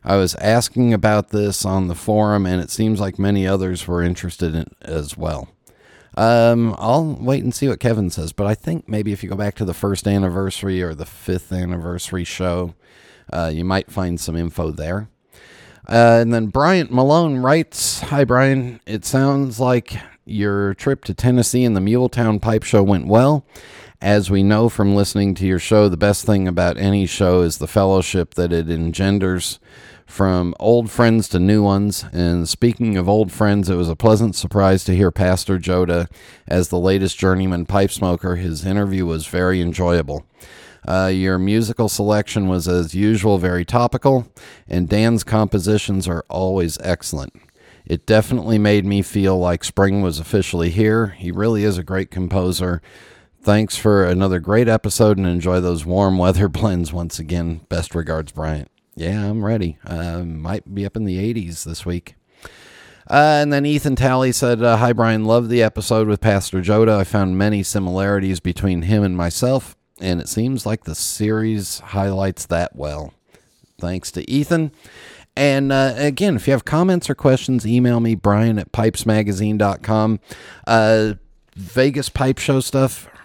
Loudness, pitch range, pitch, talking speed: -18 LUFS, 90-115 Hz, 100 Hz, 170 wpm